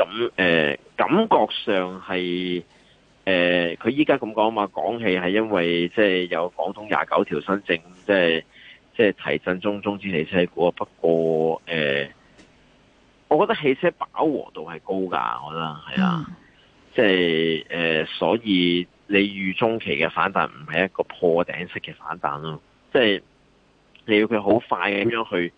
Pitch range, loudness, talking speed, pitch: 80-100 Hz, -22 LUFS, 230 characters per minute, 90 Hz